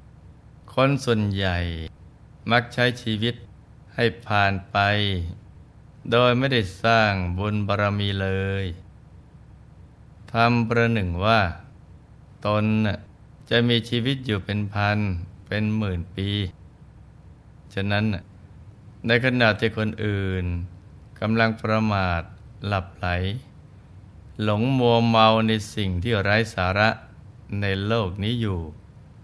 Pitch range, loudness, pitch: 95-115 Hz, -23 LUFS, 105 Hz